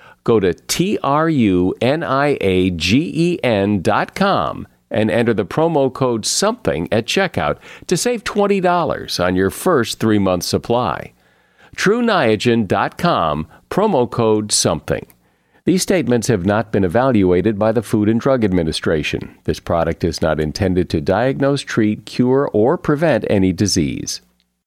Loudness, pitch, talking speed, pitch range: -17 LUFS, 105 Hz, 120 wpm, 95-130 Hz